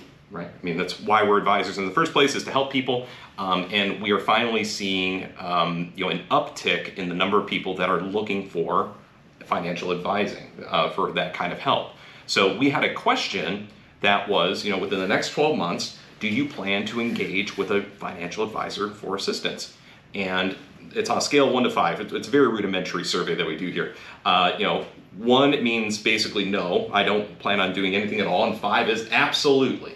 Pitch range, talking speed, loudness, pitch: 95-110 Hz, 210 wpm, -23 LUFS, 100 Hz